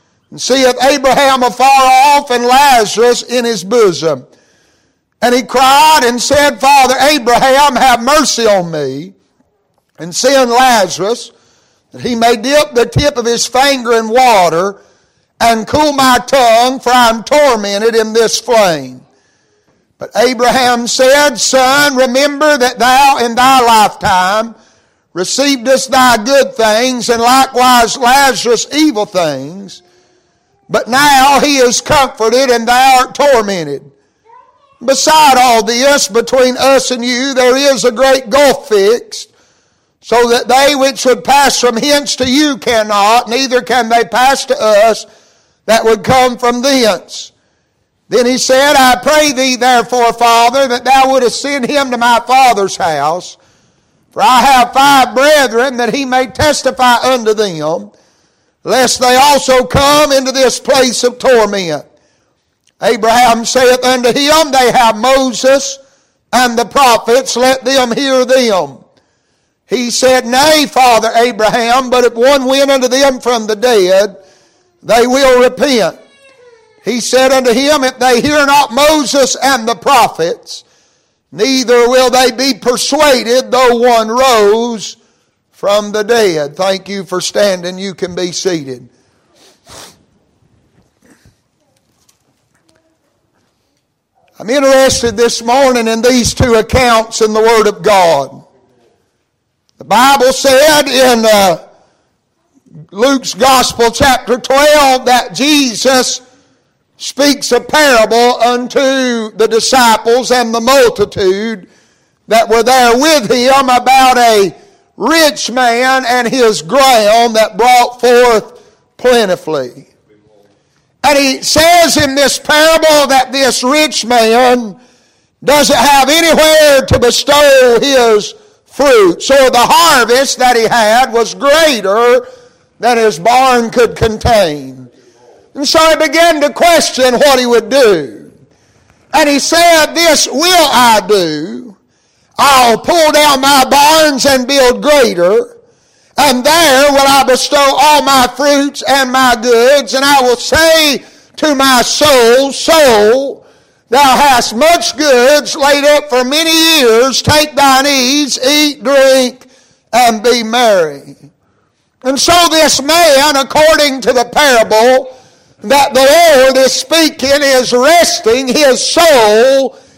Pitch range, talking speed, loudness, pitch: 235-280 Hz, 130 wpm, -8 LUFS, 255 Hz